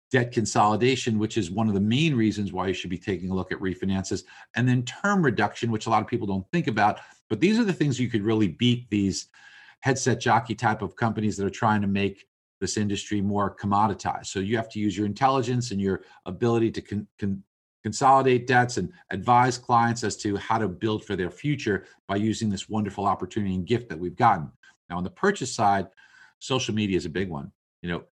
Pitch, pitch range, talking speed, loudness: 105 Hz, 100-120 Hz, 220 wpm, -25 LUFS